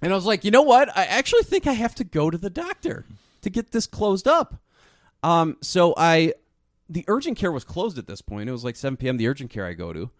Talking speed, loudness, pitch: 260 wpm, -22 LUFS, 170 Hz